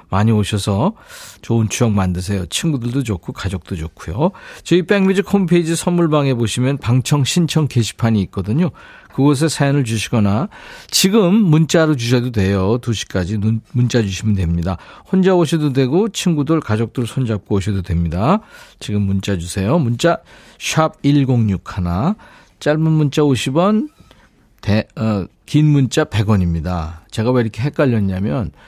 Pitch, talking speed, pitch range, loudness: 120 Hz, 295 characters per minute, 100-155 Hz, -17 LUFS